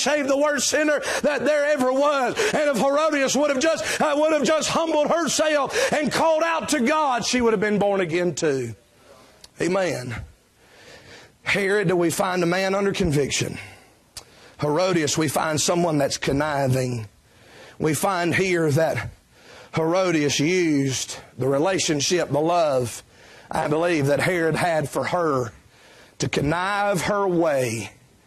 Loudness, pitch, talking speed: -22 LUFS, 180 Hz, 140 wpm